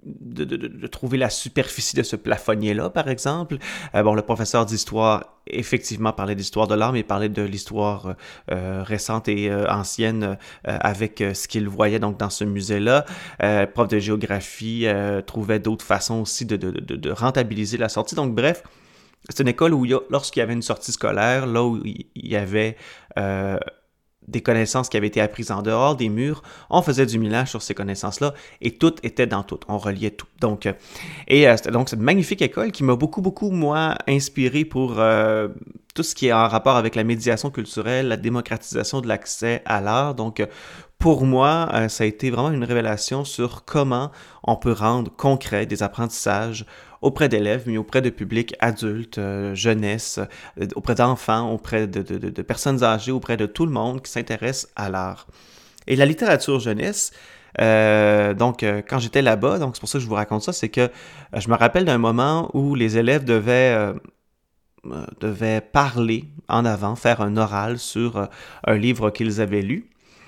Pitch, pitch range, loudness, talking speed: 115 Hz, 105-130 Hz, -21 LUFS, 190 wpm